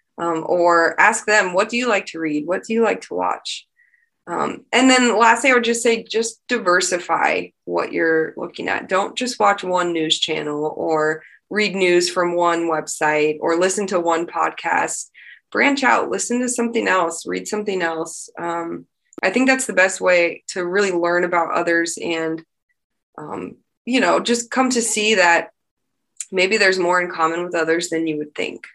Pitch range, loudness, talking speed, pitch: 165-230 Hz, -18 LUFS, 185 wpm, 180 Hz